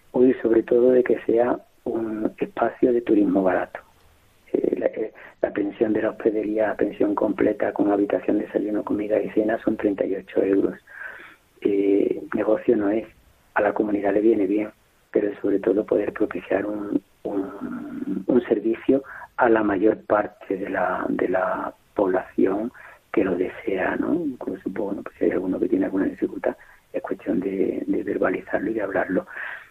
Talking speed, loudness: 165 wpm, -23 LUFS